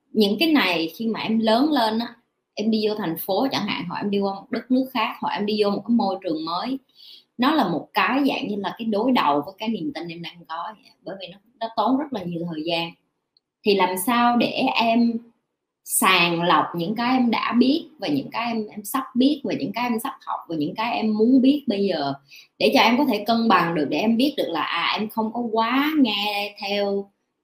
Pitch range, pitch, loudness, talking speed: 195-245 Hz, 220 Hz, -22 LUFS, 250 wpm